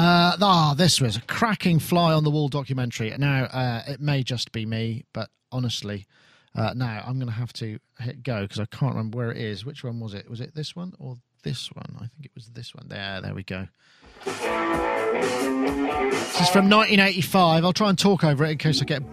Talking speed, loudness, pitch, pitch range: 225 wpm, -23 LUFS, 130 Hz, 115-155 Hz